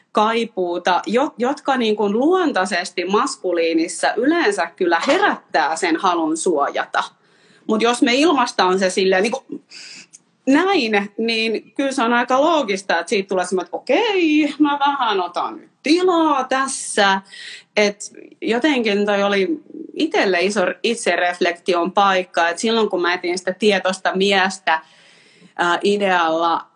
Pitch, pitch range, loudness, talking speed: 210 Hz, 185-275 Hz, -18 LUFS, 125 wpm